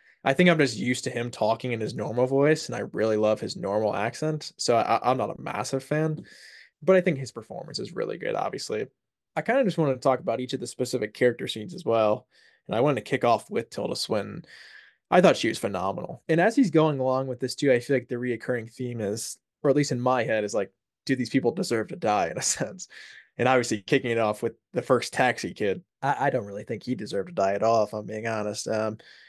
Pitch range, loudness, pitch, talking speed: 110-135 Hz, -26 LUFS, 125 Hz, 250 wpm